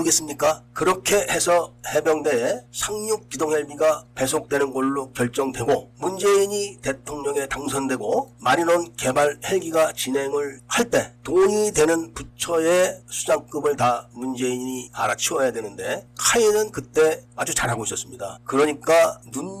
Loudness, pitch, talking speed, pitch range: -22 LUFS, 145 Hz, 310 characters per minute, 130-165 Hz